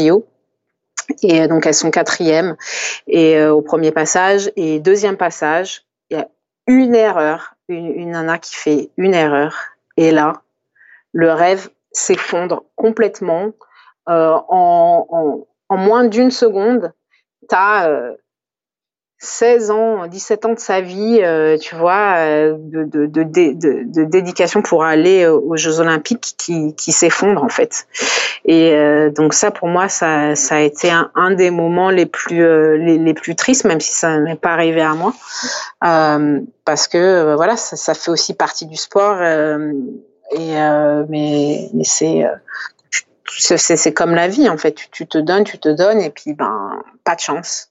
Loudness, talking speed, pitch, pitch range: -14 LUFS, 165 wpm, 165 Hz, 155-200 Hz